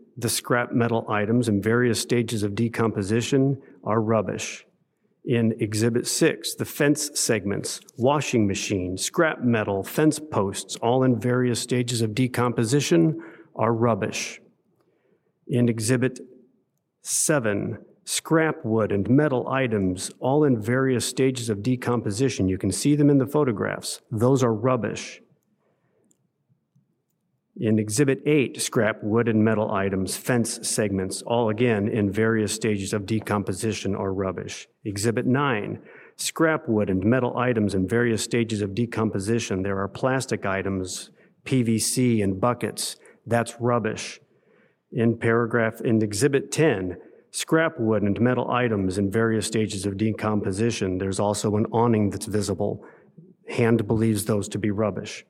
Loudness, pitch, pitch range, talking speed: -24 LUFS, 115 Hz, 105-125 Hz, 135 wpm